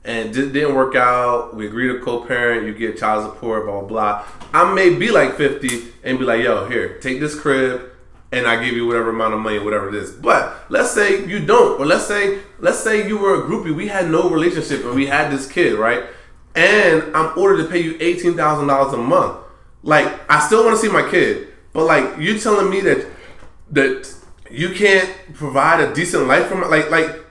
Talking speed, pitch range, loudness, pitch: 215 wpm, 120-190 Hz, -16 LUFS, 150 Hz